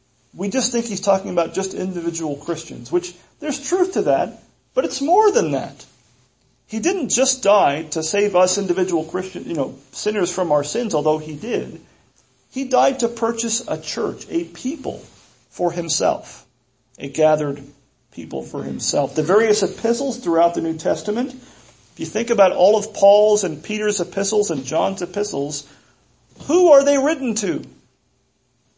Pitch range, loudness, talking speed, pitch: 155-235 Hz, -19 LUFS, 160 wpm, 190 Hz